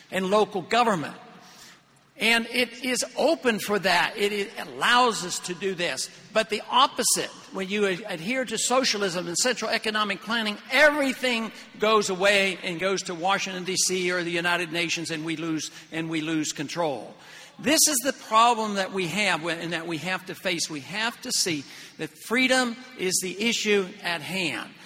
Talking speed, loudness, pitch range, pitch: 170 wpm, -24 LUFS, 175-230 Hz, 195 Hz